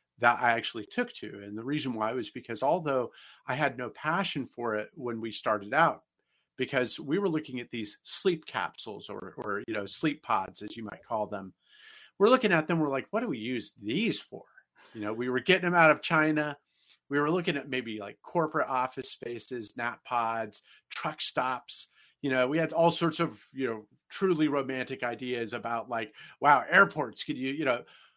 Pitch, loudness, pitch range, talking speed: 130 Hz, -30 LUFS, 115-160 Hz, 200 wpm